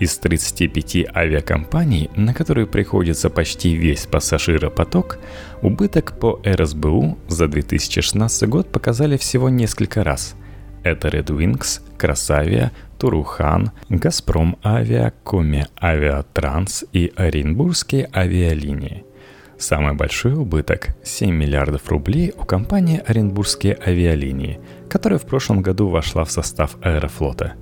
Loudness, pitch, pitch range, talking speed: -19 LUFS, 90 Hz, 75-110 Hz, 105 wpm